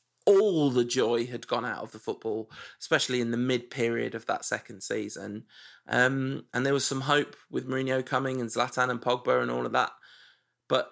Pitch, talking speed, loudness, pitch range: 125 Hz, 200 wpm, -28 LUFS, 120-135 Hz